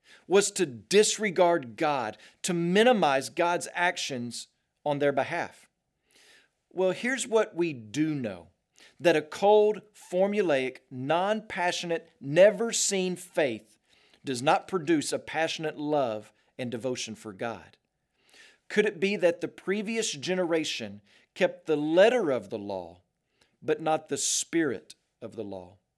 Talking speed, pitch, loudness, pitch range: 130 wpm, 165 Hz, -27 LUFS, 130-195 Hz